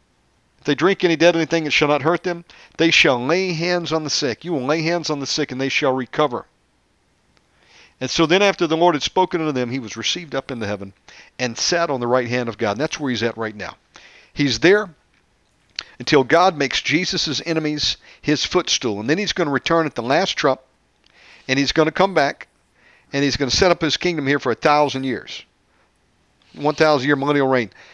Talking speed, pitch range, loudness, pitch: 220 wpm, 130-165 Hz, -19 LUFS, 150 Hz